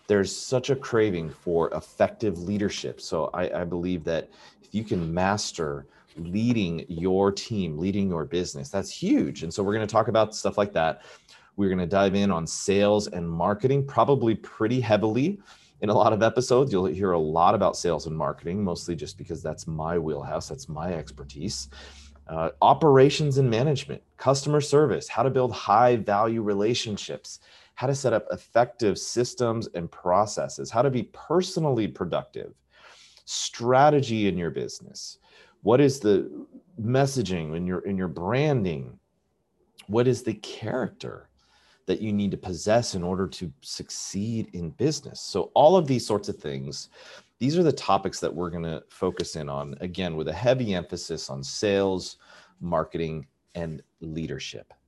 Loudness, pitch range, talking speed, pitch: -25 LUFS, 85-120 Hz, 165 wpm, 100 Hz